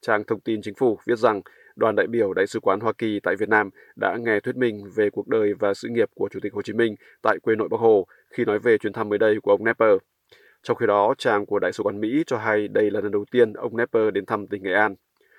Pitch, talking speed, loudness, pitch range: 110 Hz, 280 wpm, -23 LUFS, 105-130 Hz